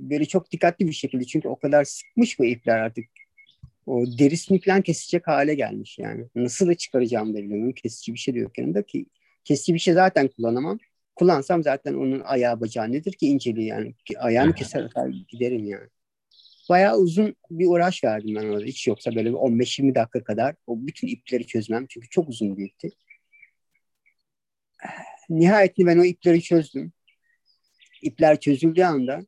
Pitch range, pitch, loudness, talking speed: 120-175 Hz, 140 Hz, -22 LUFS, 160 wpm